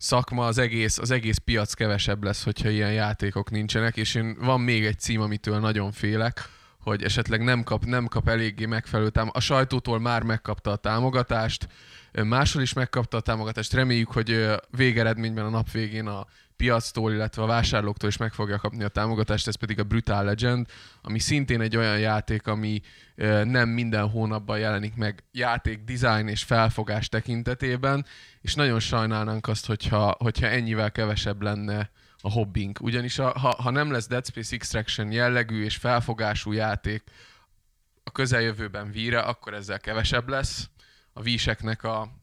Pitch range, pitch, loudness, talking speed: 105-120 Hz, 110 Hz, -26 LUFS, 160 wpm